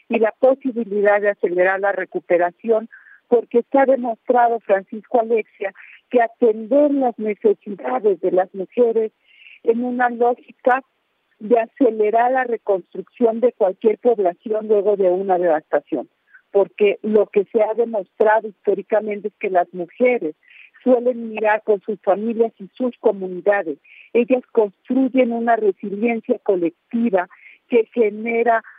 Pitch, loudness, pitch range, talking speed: 220 Hz, -19 LUFS, 200-240 Hz, 125 wpm